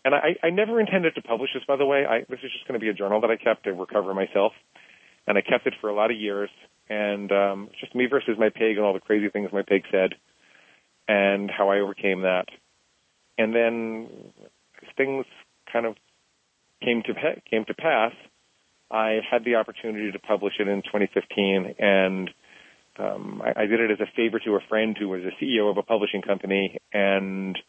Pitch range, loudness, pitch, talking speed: 100-115 Hz, -25 LUFS, 105 Hz, 210 wpm